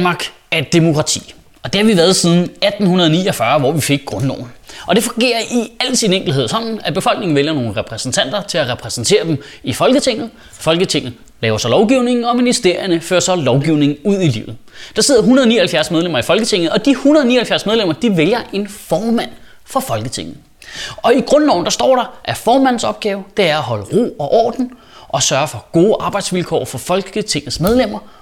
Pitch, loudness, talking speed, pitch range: 190 Hz, -14 LUFS, 180 wpm, 155-230 Hz